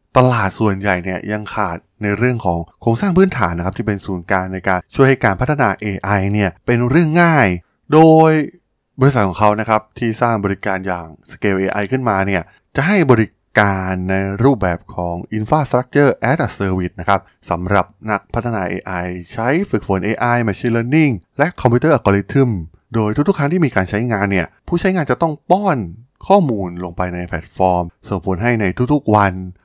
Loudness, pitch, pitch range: -16 LUFS, 105 Hz, 95-130 Hz